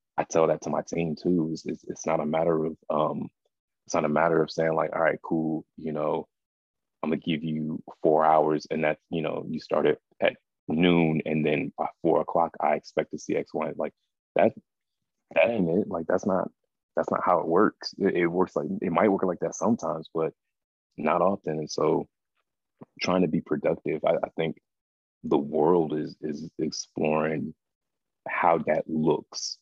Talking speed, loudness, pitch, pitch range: 190 wpm, -27 LUFS, 80 Hz, 75-80 Hz